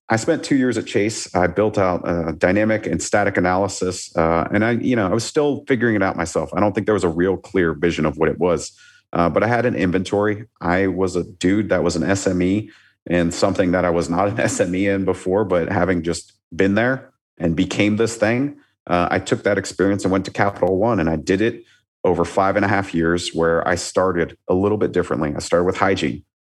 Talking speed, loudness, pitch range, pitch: 235 wpm, -19 LUFS, 85-105 Hz, 95 Hz